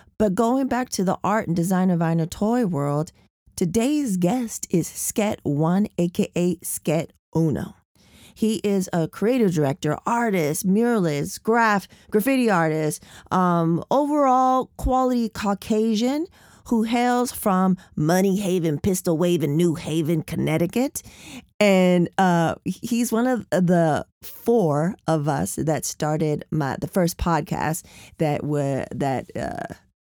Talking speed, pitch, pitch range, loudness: 130 wpm, 185 Hz, 160-225 Hz, -22 LUFS